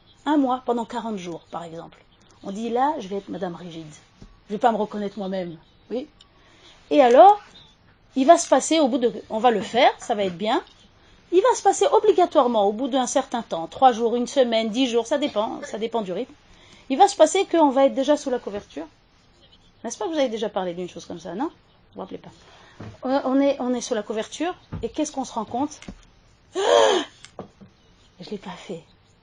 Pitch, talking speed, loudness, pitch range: 240 Hz, 225 wpm, -21 LUFS, 205-290 Hz